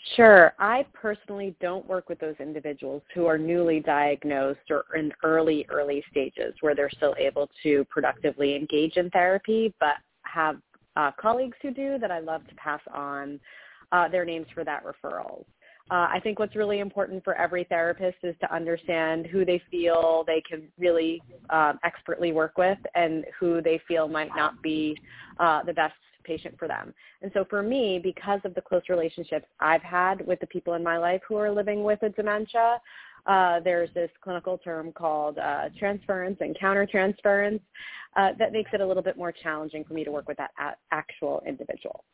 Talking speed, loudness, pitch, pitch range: 185 wpm, -26 LUFS, 170 Hz, 155-195 Hz